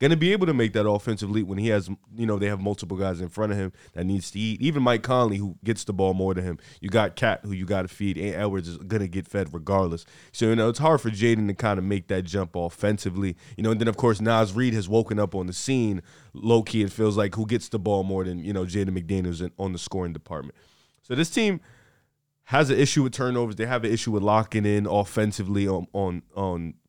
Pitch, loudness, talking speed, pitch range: 105 Hz, -25 LUFS, 265 wpm, 95-115 Hz